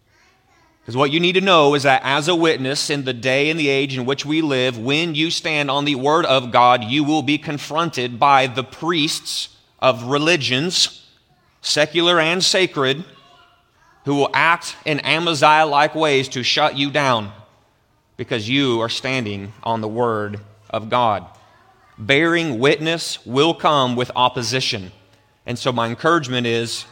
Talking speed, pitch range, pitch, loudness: 160 wpm, 125-155 Hz, 140 Hz, -18 LUFS